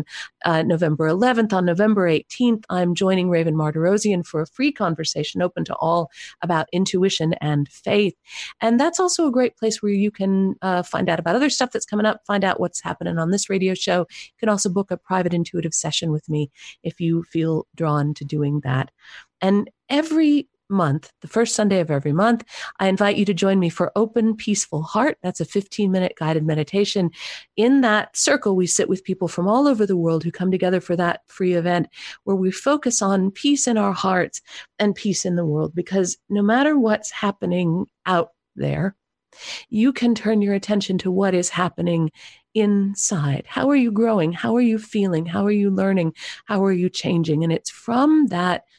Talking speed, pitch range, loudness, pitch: 195 wpm, 170-210 Hz, -21 LUFS, 190 Hz